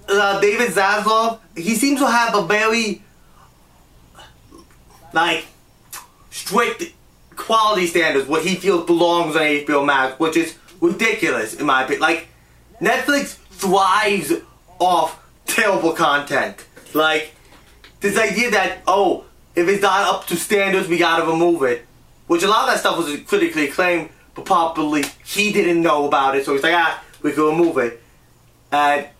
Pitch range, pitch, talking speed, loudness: 155-210 Hz, 175 Hz, 150 wpm, -18 LUFS